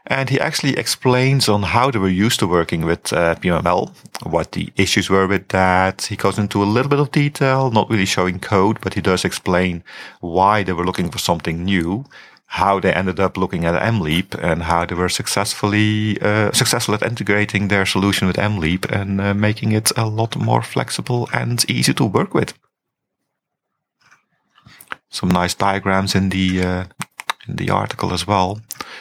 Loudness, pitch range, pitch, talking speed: -18 LUFS, 95-110 Hz, 100 Hz, 180 wpm